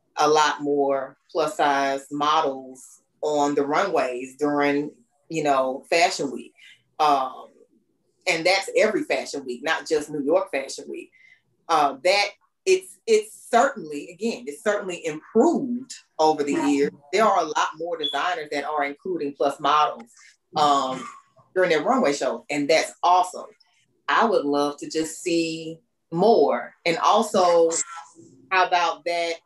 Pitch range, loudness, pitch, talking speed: 145-205 Hz, -23 LUFS, 160 Hz, 140 wpm